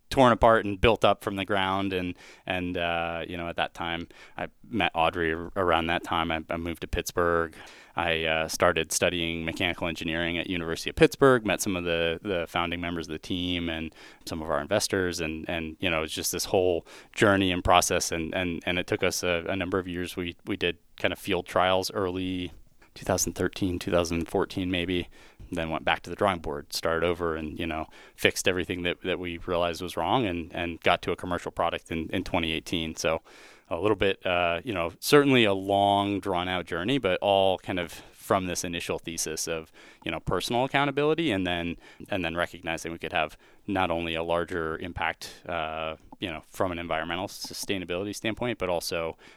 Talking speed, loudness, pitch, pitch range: 200 wpm, -27 LUFS, 85 Hz, 85-95 Hz